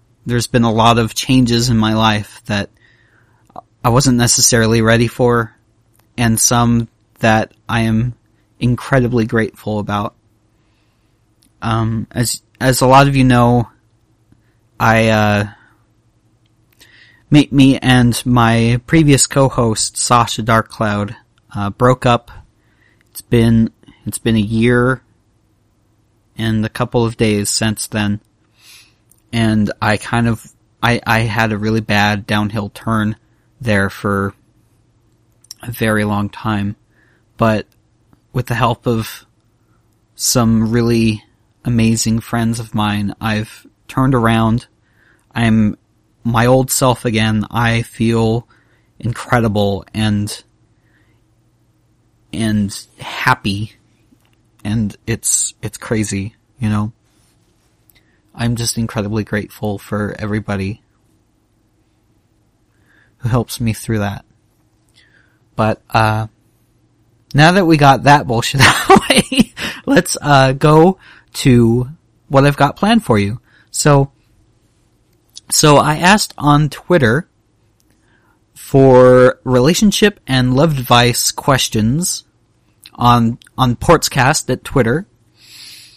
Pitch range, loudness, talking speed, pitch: 110-120 Hz, -14 LUFS, 110 wpm, 115 Hz